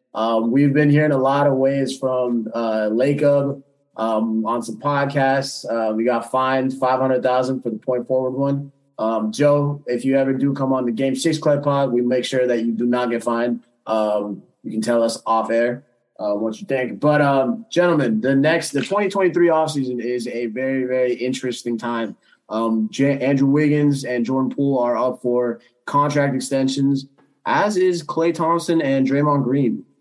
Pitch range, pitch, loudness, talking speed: 120-140 Hz, 130 Hz, -20 LUFS, 185 wpm